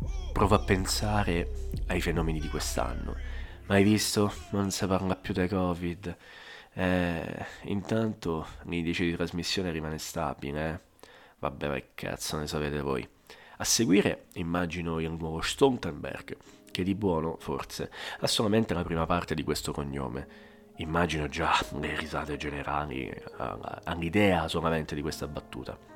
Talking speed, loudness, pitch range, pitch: 130 wpm, -30 LUFS, 75-90 Hz, 80 Hz